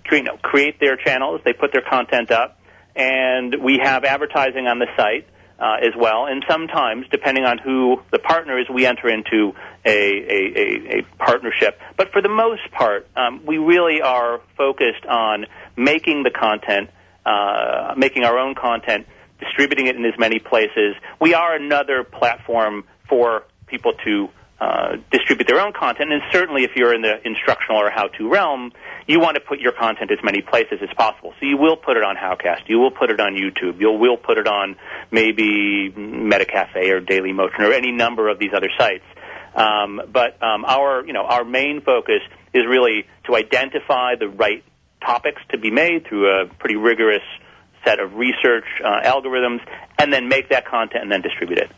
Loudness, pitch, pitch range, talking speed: -18 LUFS, 130 Hz, 110-155 Hz, 185 wpm